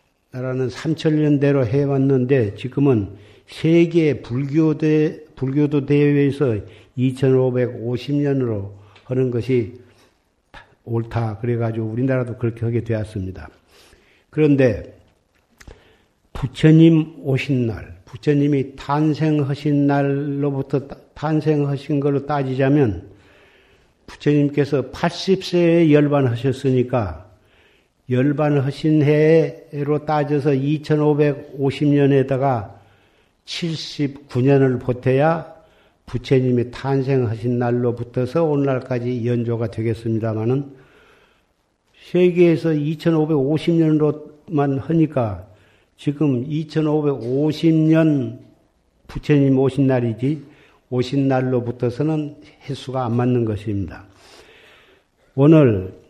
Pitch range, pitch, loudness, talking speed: 120-150 Hz, 135 Hz, -19 LUFS, 200 characters per minute